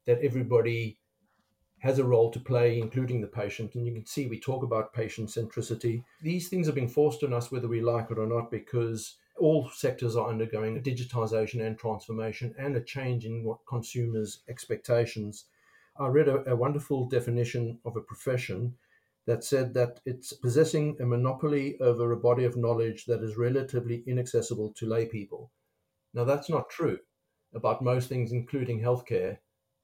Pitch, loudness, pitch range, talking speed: 120 Hz, -30 LUFS, 115-130 Hz, 170 wpm